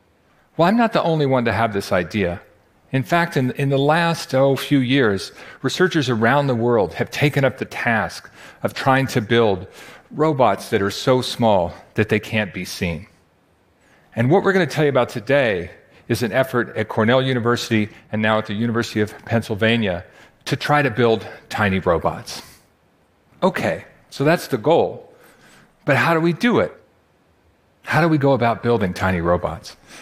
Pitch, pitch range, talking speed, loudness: 125 Hz, 110-145 Hz, 180 wpm, -19 LUFS